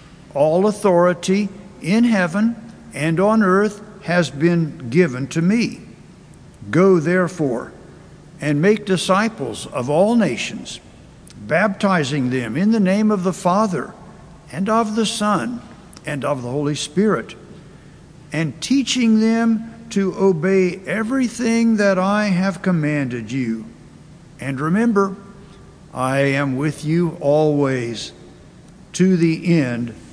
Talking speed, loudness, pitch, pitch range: 115 wpm, -18 LUFS, 180 Hz, 150-205 Hz